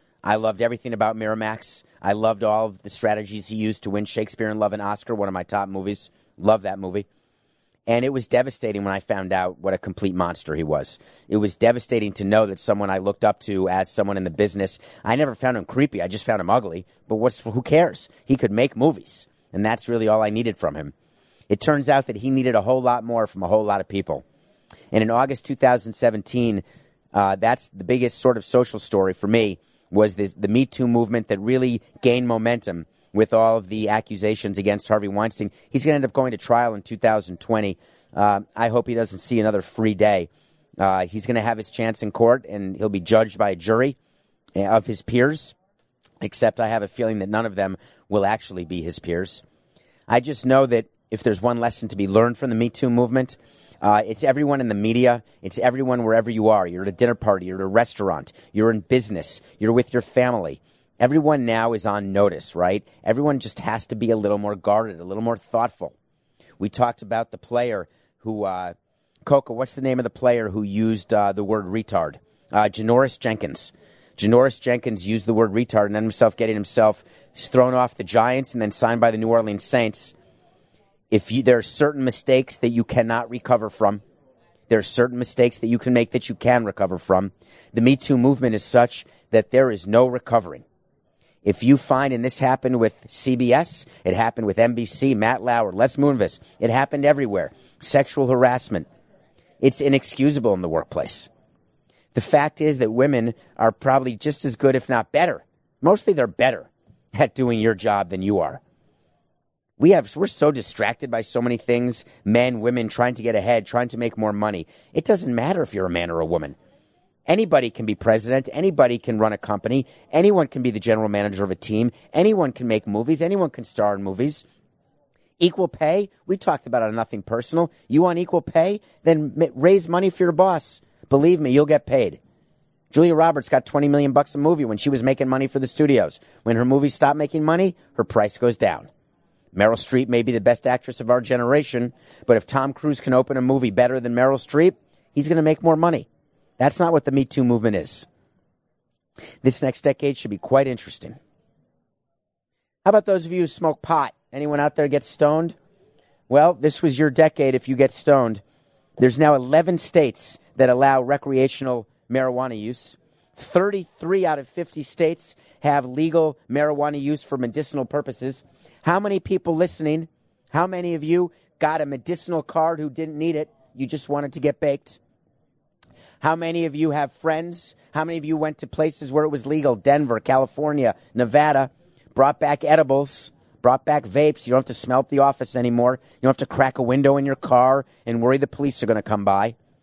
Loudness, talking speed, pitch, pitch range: -21 LUFS, 205 wpm, 120 Hz, 110-140 Hz